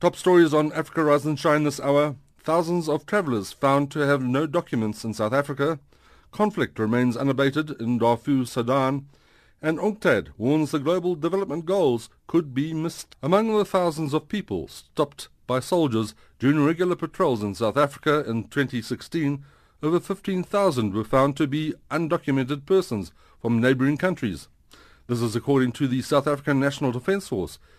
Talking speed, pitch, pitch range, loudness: 155 wpm, 145 Hz, 130-165 Hz, -24 LUFS